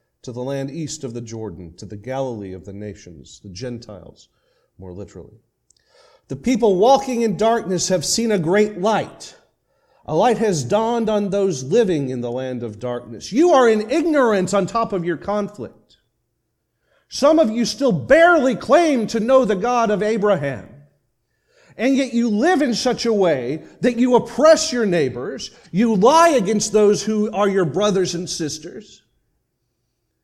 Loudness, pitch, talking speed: -18 LUFS, 205 Hz, 165 wpm